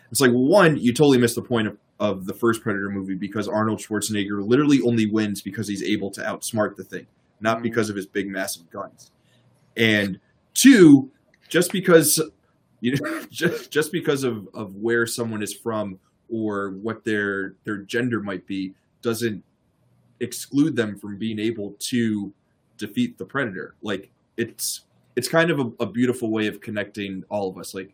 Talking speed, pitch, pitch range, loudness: 175 wpm, 110 Hz, 100-120 Hz, -22 LUFS